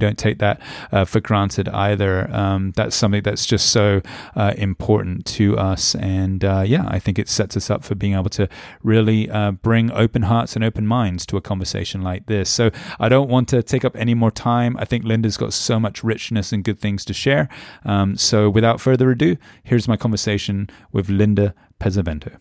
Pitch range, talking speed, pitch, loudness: 100-115 Hz, 205 wpm, 105 Hz, -19 LUFS